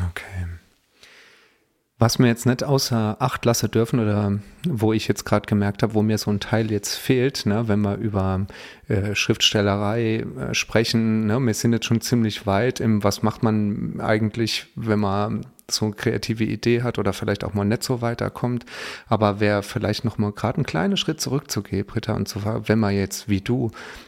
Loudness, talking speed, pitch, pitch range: -22 LUFS, 185 wpm, 110 Hz, 105-120 Hz